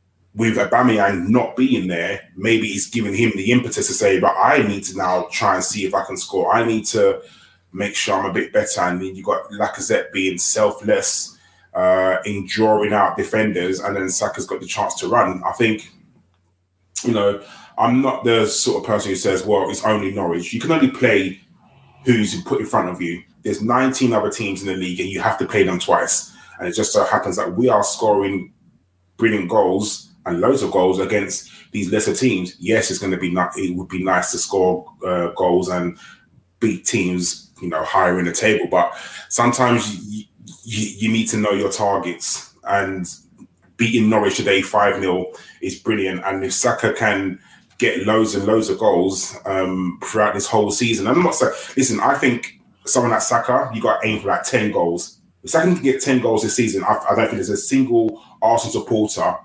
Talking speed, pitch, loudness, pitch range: 205 wpm, 100 Hz, -18 LUFS, 90-115 Hz